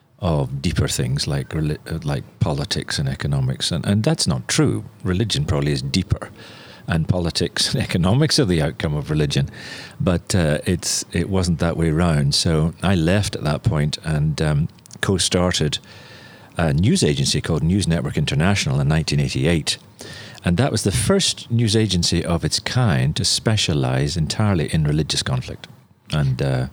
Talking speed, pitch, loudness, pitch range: 155 wpm, 85 Hz, -20 LUFS, 75-110 Hz